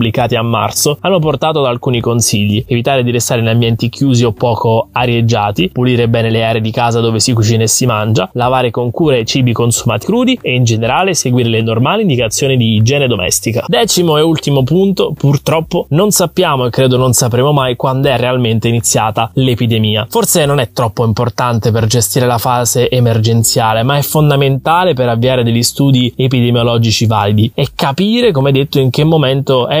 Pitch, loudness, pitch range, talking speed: 125 Hz, -11 LUFS, 115-140 Hz, 180 wpm